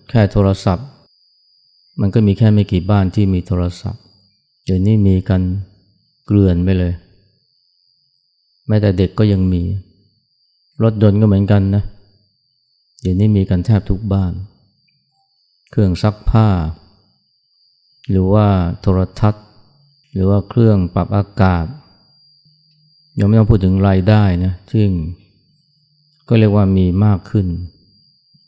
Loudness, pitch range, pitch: -15 LUFS, 95-130 Hz, 105 Hz